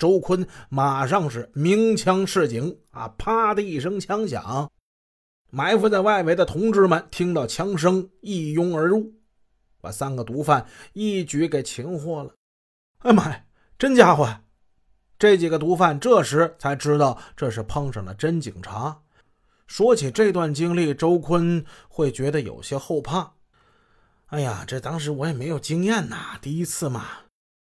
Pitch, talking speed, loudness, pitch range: 160 Hz, 215 characters per minute, -22 LUFS, 135-185 Hz